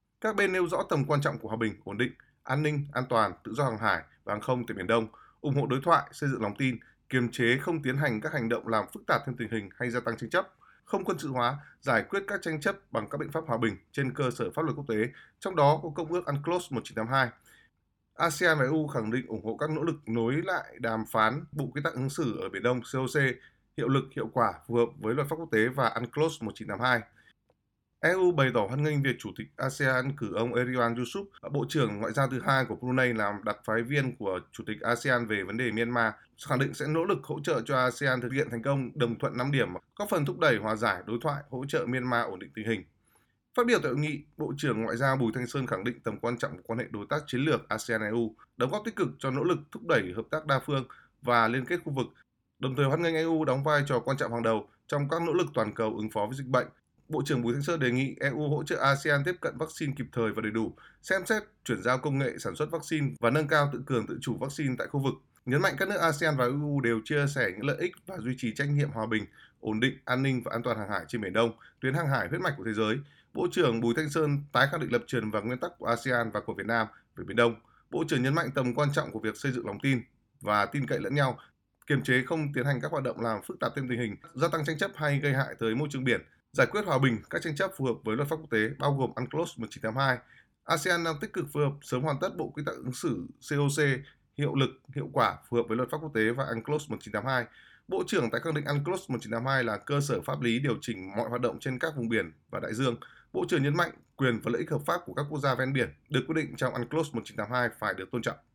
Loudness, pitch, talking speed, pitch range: -30 LUFS, 130 Hz, 270 wpm, 115-150 Hz